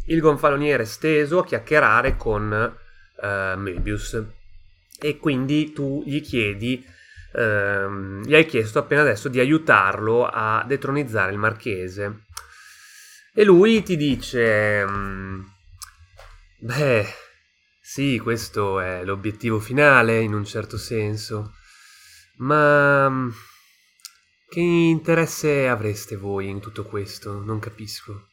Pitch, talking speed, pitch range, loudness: 110 Hz, 110 wpm, 100-145 Hz, -21 LUFS